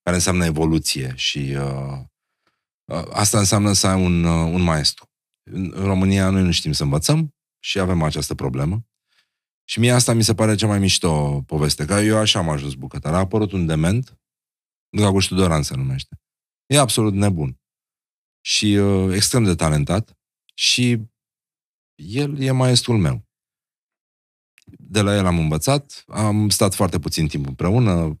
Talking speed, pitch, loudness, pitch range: 155 wpm, 95 Hz, -19 LUFS, 80-110 Hz